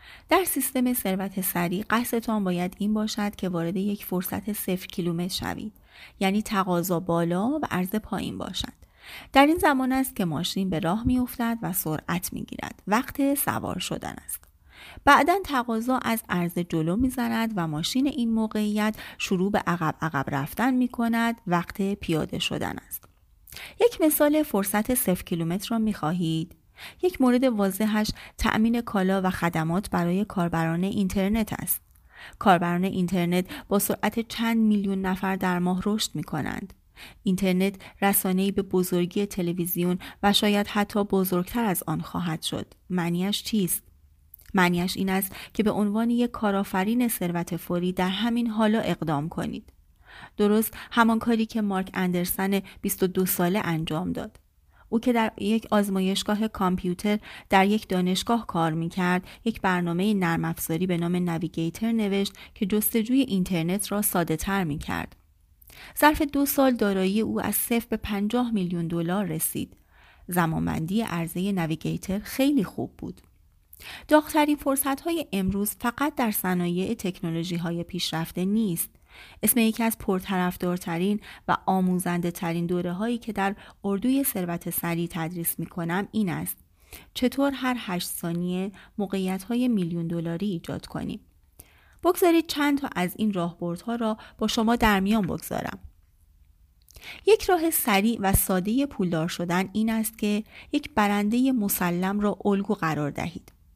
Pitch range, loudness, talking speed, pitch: 175-225 Hz, -26 LUFS, 140 wpm, 195 Hz